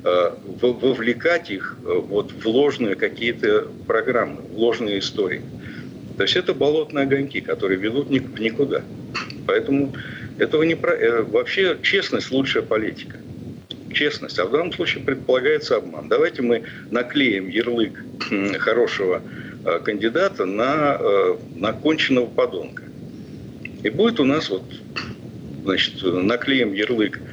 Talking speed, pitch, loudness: 115 wpm, 395 Hz, -21 LUFS